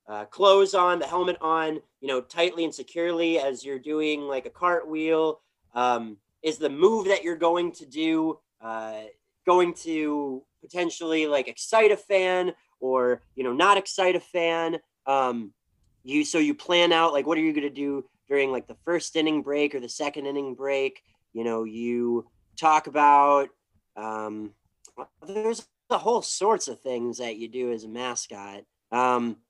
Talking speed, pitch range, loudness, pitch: 170 wpm, 120-170 Hz, -25 LUFS, 145 Hz